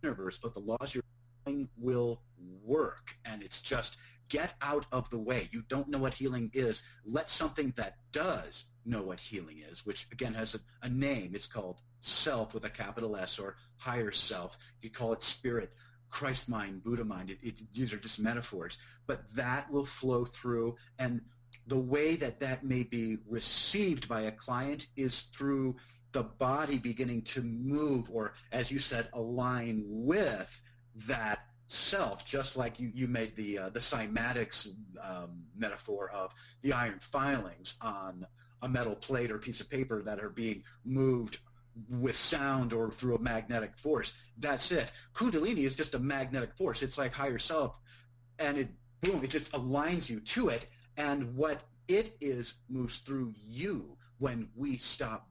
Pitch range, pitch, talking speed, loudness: 115-135 Hz, 120 Hz, 170 wpm, -35 LUFS